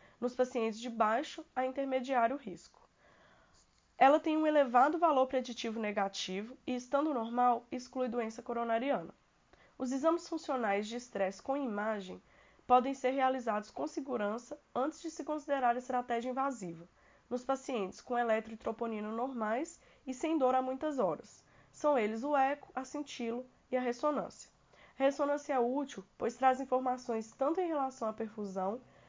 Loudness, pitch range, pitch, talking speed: -34 LUFS, 230-275 Hz, 255 Hz, 145 wpm